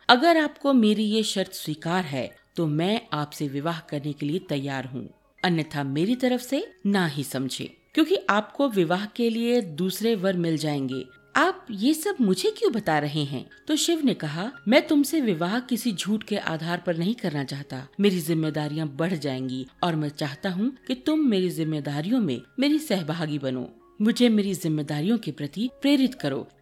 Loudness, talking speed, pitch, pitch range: -25 LUFS, 175 wpm, 185 Hz, 150-240 Hz